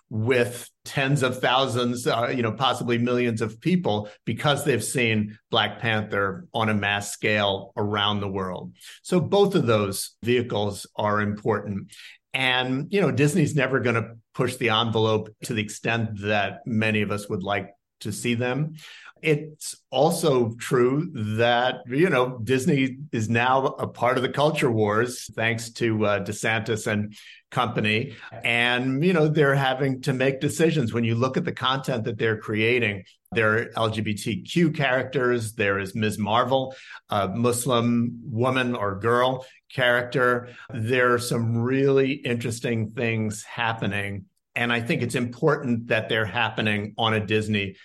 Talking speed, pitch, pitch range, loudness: 155 wpm, 120 Hz, 110-130 Hz, -24 LUFS